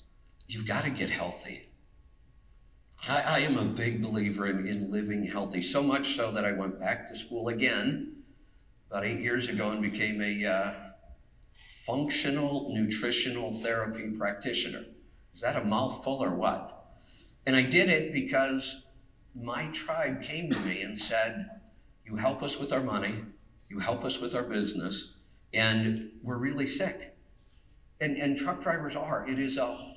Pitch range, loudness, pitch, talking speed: 100-130 Hz, -30 LUFS, 110 Hz, 160 wpm